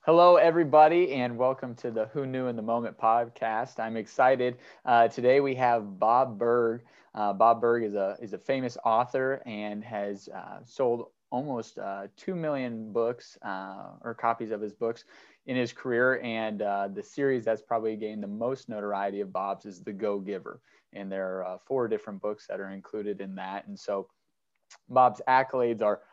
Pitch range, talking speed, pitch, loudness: 105-130 Hz, 185 wpm, 115 Hz, -28 LUFS